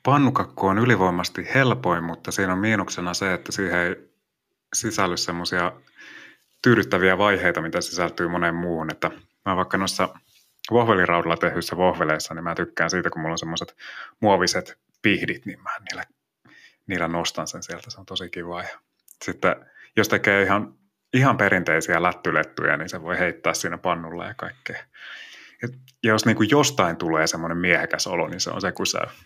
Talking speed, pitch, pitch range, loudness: 160 wpm, 90 Hz, 85-100 Hz, -22 LUFS